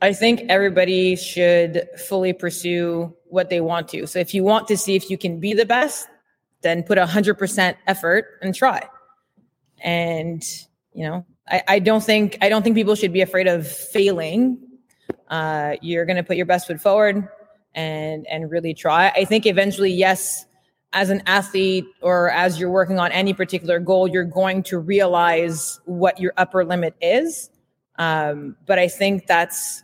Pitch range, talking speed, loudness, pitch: 170-200 Hz, 175 wpm, -19 LUFS, 185 Hz